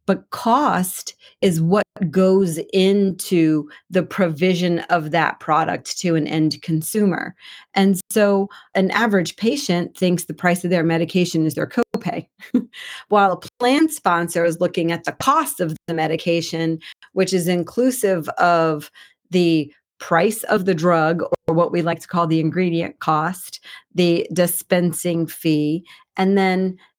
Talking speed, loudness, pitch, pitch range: 140 wpm, -19 LUFS, 180 Hz, 165-195 Hz